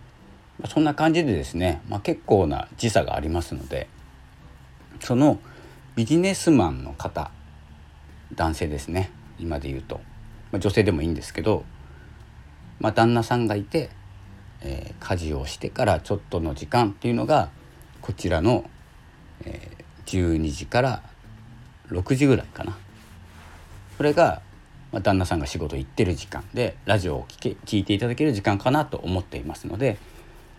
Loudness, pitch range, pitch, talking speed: -24 LUFS, 75-110 Hz, 95 Hz, 290 characters per minute